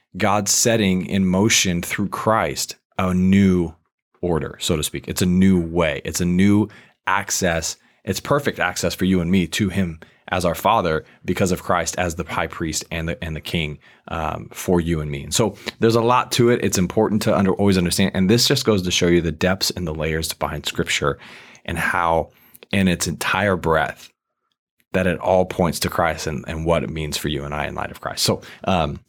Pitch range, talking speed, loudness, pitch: 80-100 Hz, 215 wpm, -20 LUFS, 90 Hz